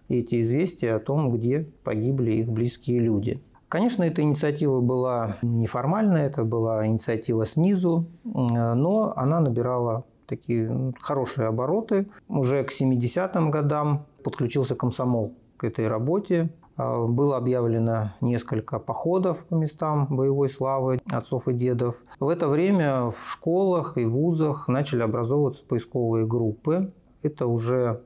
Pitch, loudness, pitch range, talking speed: 130 Hz, -25 LUFS, 120-150 Hz, 120 wpm